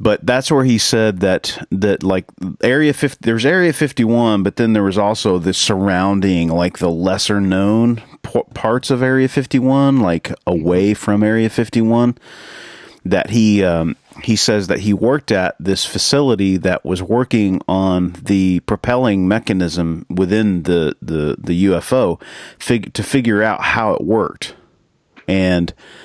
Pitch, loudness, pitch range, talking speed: 105 Hz, -16 LUFS, 95-120 Hz, 150 wpm